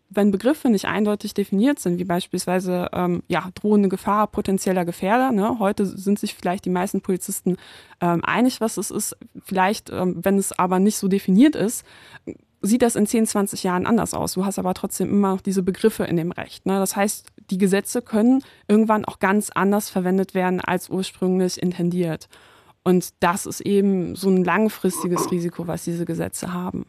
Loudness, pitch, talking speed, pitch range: -22 LUFS, 195 Hz, 185 wpm, 180-210 Hz